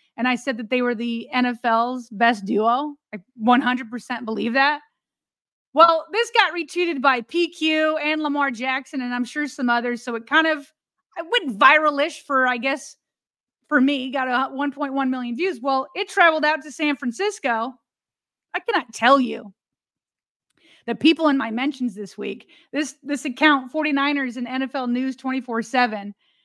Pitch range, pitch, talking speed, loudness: 245-300 Hz, 270 Hz, 160 wpm, -21 LUFS